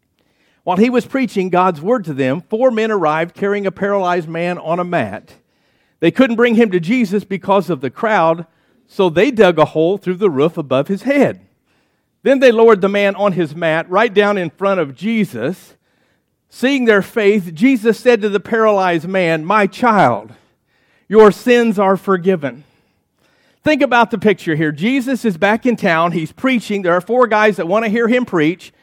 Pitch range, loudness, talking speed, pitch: 175-230 Hz, -15 LUFS, 185 wpm, 200 Hz